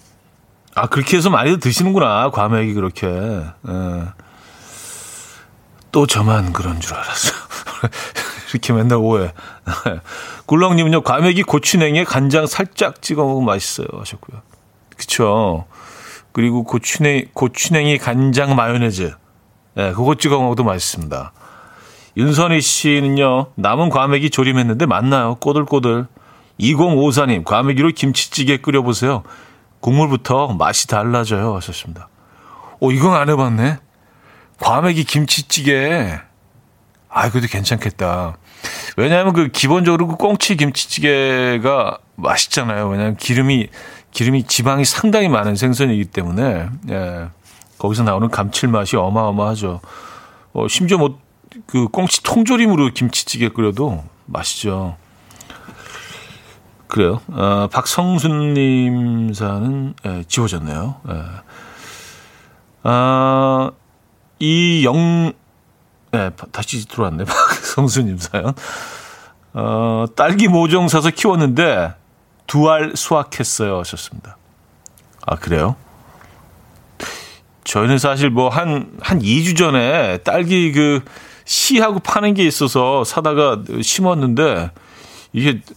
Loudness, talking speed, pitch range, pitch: -16 LUFS, 245 characters per minute, 105-150 Hz, 125 Hz